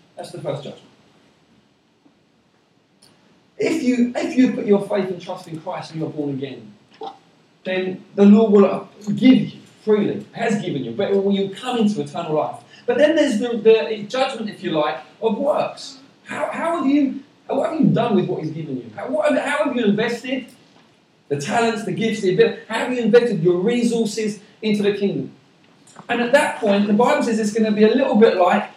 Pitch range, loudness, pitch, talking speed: 190-245 Hz, -19 LUFS, 220 Hz, 200 wpm